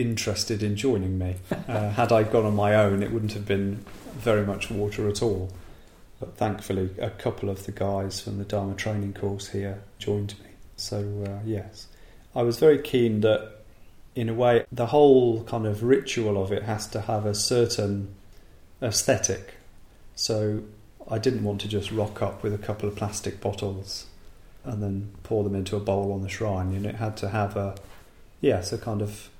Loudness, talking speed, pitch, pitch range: -26 LUFS, 190 wpm, 105 Hz, 100-110 Hz